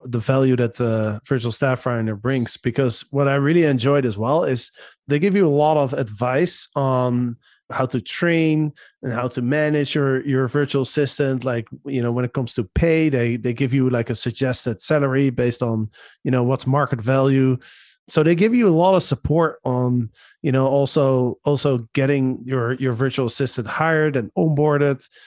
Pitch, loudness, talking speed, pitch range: 135 Hz, -20 LUFS, 190 wpm, 125-145 Hz